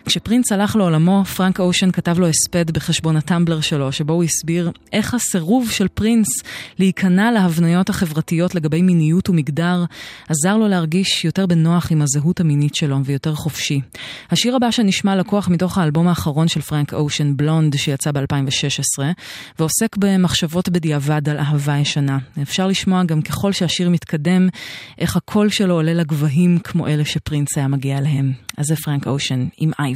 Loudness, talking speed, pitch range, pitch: -17 LUFS, 155 wpm, 150-185 Hz, 165 Hz